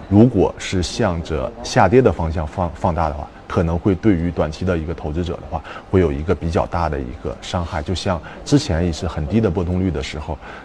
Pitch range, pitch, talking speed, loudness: 80-95 Hz, 85 Hz, 320 characters per minute, -20 LUFS